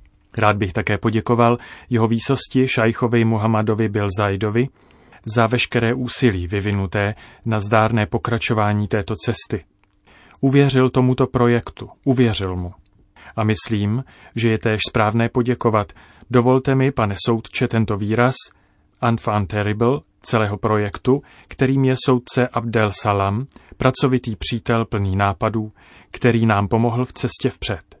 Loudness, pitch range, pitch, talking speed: -19 LUFS, 105-120 Hz, 115 Hz, 120 wpm